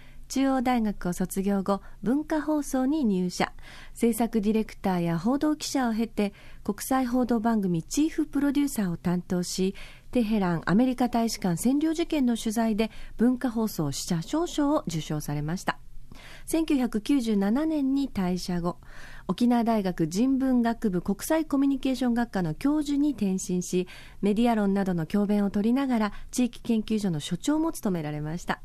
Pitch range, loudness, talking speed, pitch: 190-265 Hz, -27 LUFS, 315 characters per minute, 225 Hz